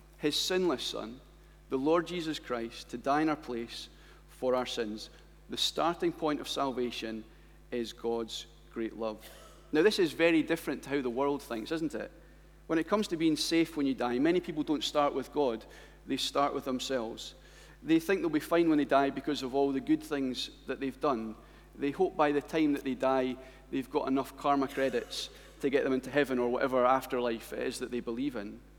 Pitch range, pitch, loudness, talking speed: 125-160 Hz, 140 Hz, -32 LUFS, 205 wpm